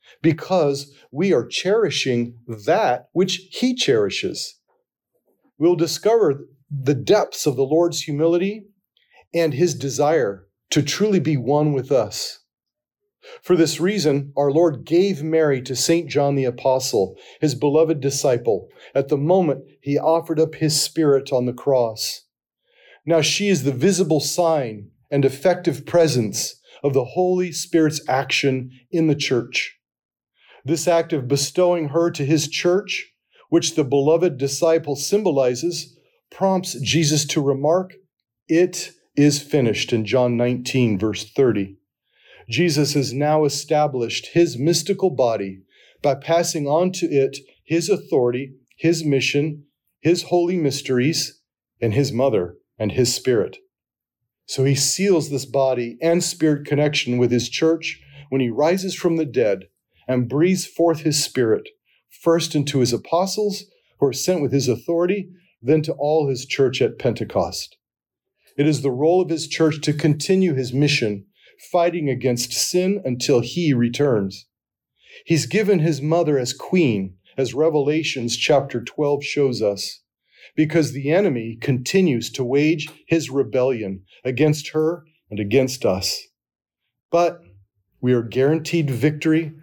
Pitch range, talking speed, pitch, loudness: 130-170 Hz, 135 wpm, 150 Hz, -20 LUFS